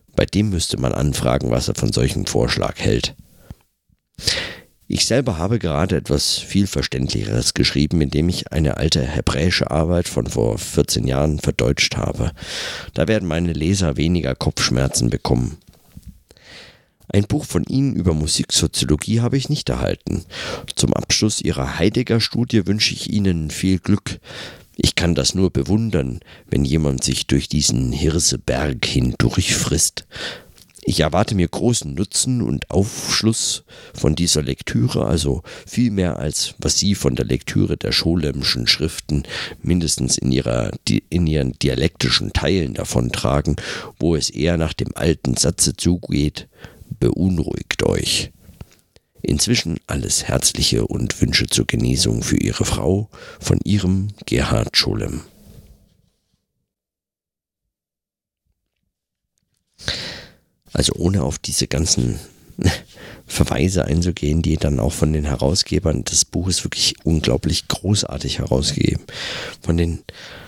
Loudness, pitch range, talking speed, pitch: -19 LUFS, 70-100 Hz, 125 wpm, 85 Hz